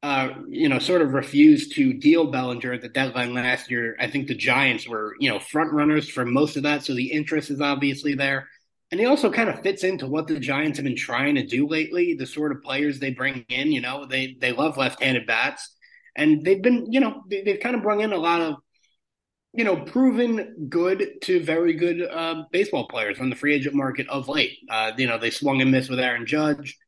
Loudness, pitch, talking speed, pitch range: -23 LUFS, 150 Hz, 230 wpm, 135-185 Hz